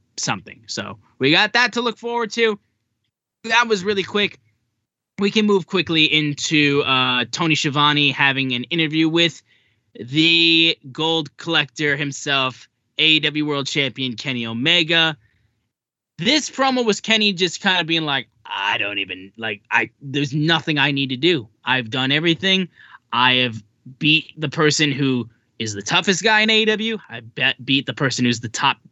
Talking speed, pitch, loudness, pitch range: 160 wpm, 145 Hz, -18 LUFS, 125-170 Hz